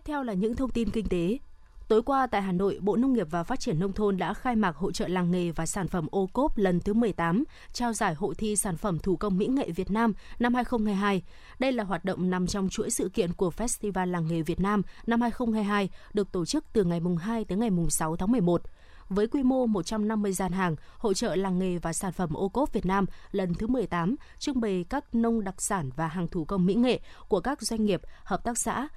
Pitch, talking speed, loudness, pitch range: 205 Hz, 240 wpm, -28 LUFS, 185-230 Hz